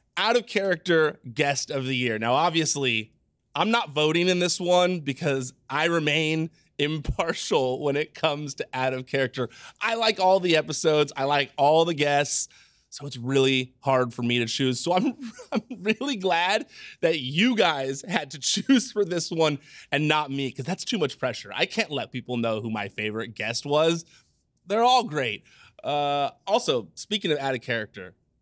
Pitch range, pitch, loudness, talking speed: 130-180 Hz, 145 Hz, -25 LUFS, 180 wpm